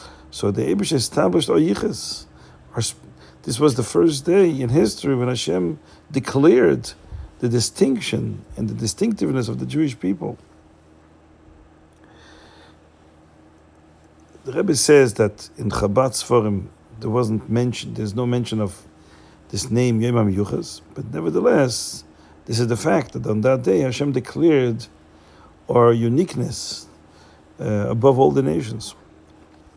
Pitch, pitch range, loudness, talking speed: 105 Hz, 80-125 Hz, -20 LUFS, 125 wpm